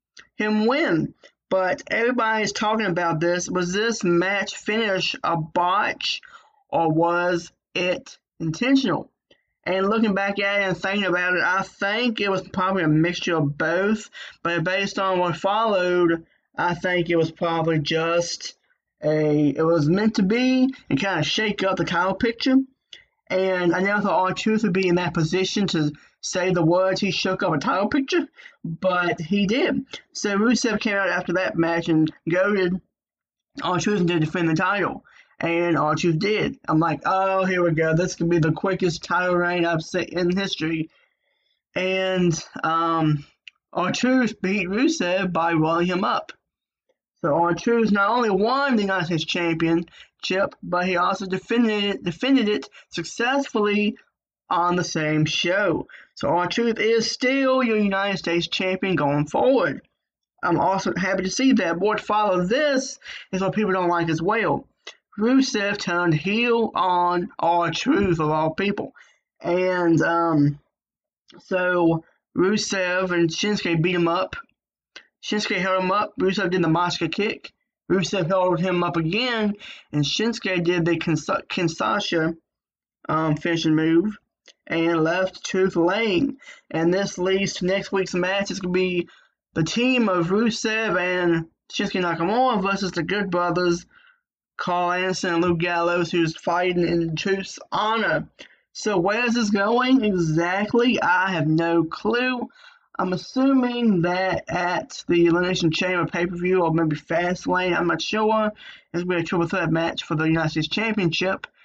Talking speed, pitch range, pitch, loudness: 155 wpm, 170-210 Hz, 185 Hz, -22 LUFS